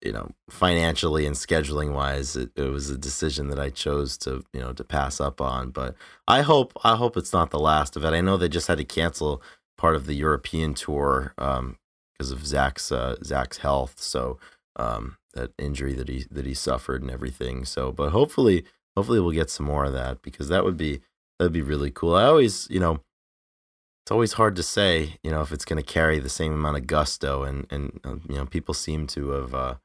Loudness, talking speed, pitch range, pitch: -25 LUFS, 225 wpm, 65-80 Hz, 70 Hz